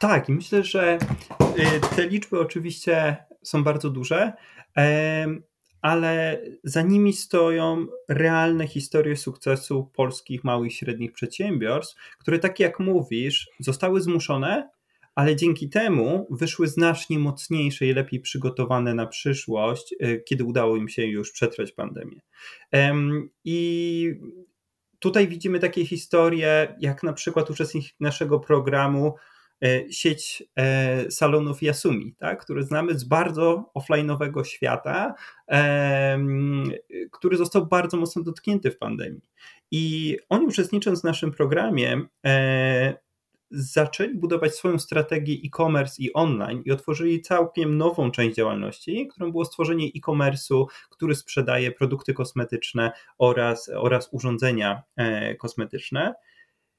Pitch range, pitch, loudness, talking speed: 135-170 Hz, 155 Hz, -24 LUFS, 110 wpm